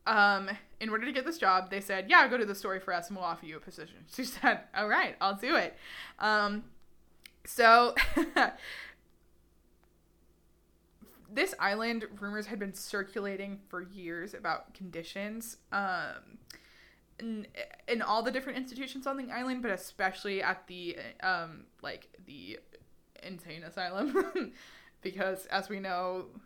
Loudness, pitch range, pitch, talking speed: -31 LUFS, 190-240 Hz, 205 Hz, 145 wpm